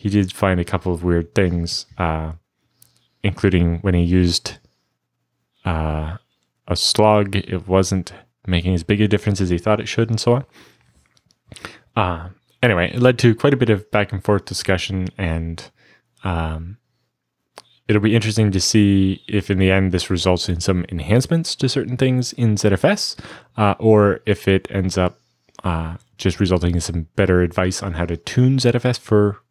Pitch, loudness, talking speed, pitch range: 95 Hz, -19 LUFS, 170 wpm, 90-105 Hz